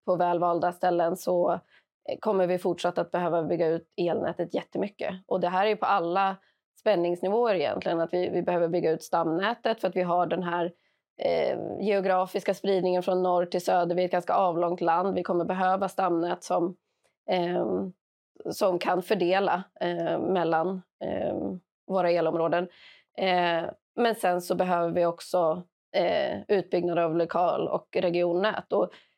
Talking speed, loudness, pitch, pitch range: 155 wpm, -27 LUFS, 180 Hz, 175-185 Hz